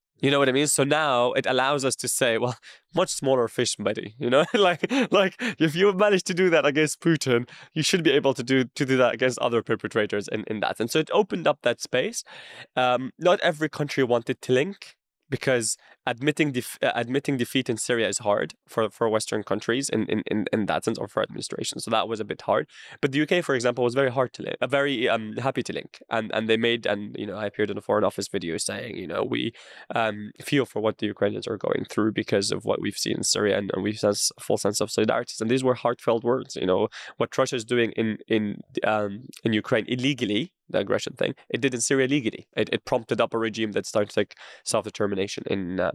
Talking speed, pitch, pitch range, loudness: 240 wpm, 125 Hz, 115-145 Hz, -25 LUFS